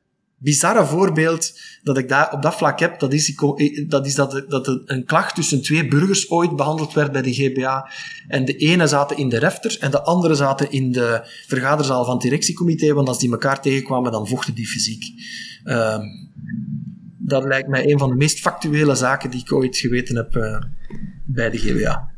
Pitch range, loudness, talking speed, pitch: 130-160 Hz, -18 LUFS, 190 wpm, 140 Hz